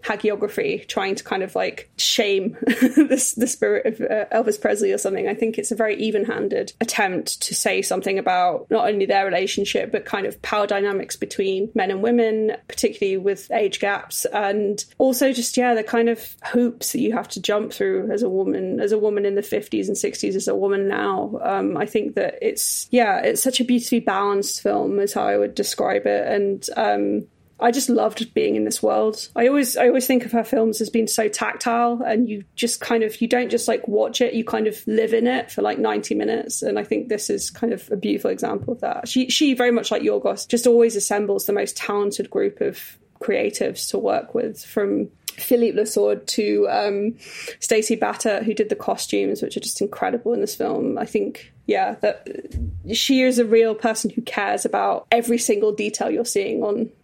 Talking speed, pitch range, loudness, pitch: 210 wpm, 205-245 Hz, -21 LUFS, 225 Hz